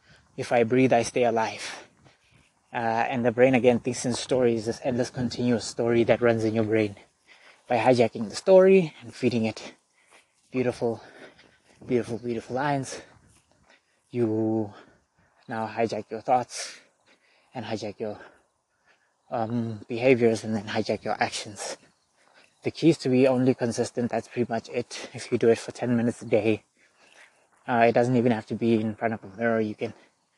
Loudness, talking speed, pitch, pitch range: -25 LUFS, 165 wpm, 115 Hz, 110-125 Hz